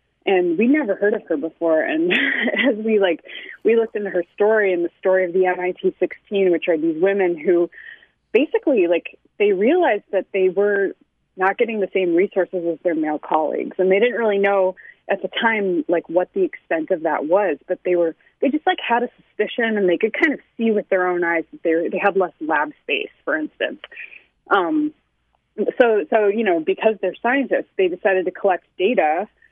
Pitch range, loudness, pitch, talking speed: 180-275 Hz, -20 LUFS, 195 Hz, 205 wpm